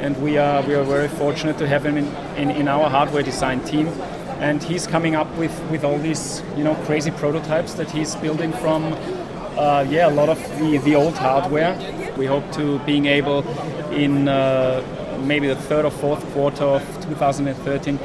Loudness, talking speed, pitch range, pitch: -20 LUFS, 190 wpm, 140-155 Hz, 150 Hz